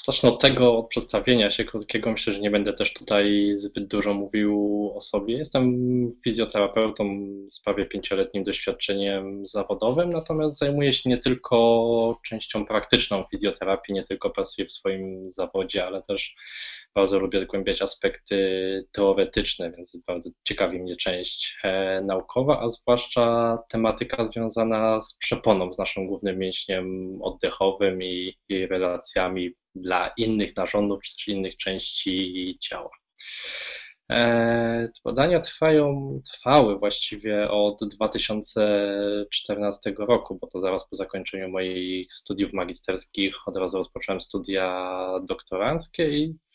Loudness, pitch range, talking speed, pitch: -25 LUFS, 95-115 Hz, 125 wpm, 105 Hz